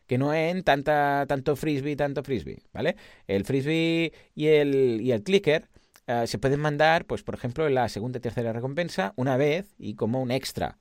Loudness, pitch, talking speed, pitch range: -26 LUFS, 140 Hz, 195 wpm, 125-155 Hz